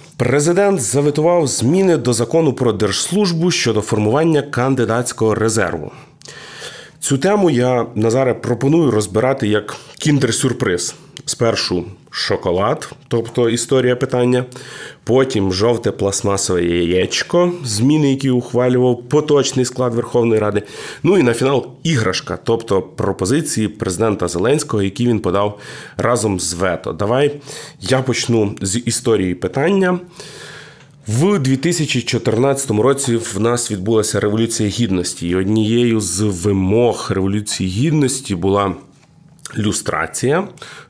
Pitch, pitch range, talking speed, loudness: 120 Hz, 105-140 Hz, 105 wpm, -16 LUFS